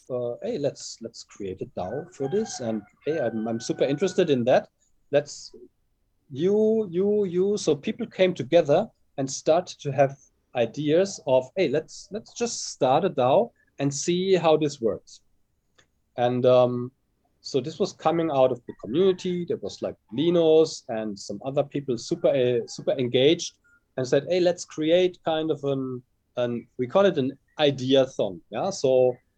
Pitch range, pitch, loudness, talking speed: 125-180 Hz, 145 Hz, -25 LUFS, 170 wpm